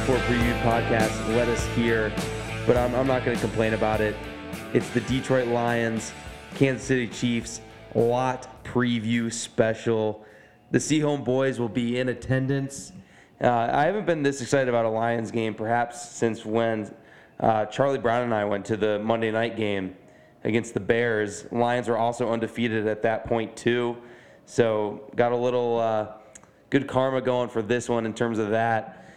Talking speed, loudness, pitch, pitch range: 170 wpm, -25 LUFS, 115 Hz, 110-120 Hz